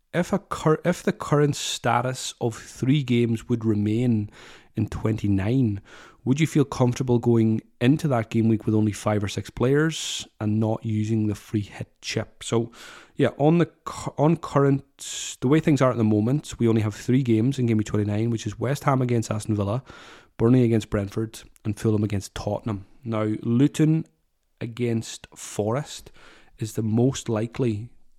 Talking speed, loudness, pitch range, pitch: 175 wpm, -24 LUFS, 110-135 Hz, 115 Hz